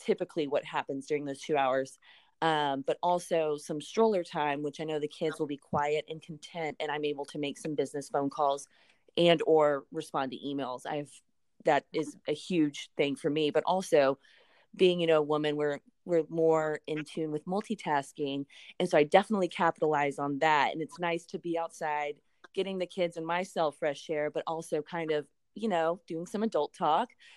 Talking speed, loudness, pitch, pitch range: 195 wpm, -31 LUFS, 155 Hz, 145-170 Hz